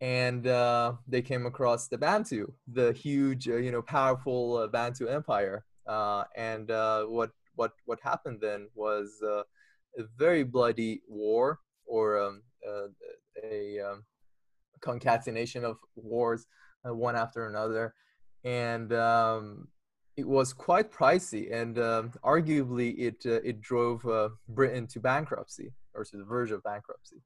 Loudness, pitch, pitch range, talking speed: -30 LUFS, 120 Hz, 110-125 Hz, 145 wpm